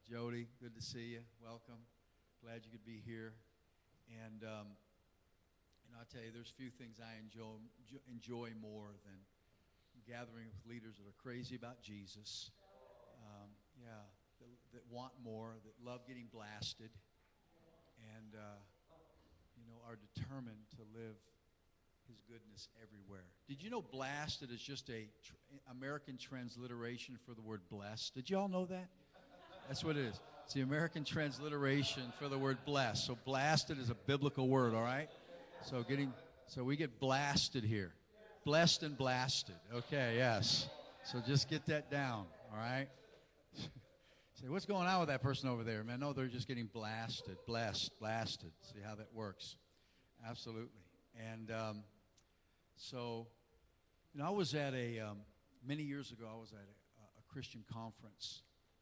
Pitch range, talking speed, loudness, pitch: 105-130 Hz, 160 wpm, -42 LUFS, 115 Hz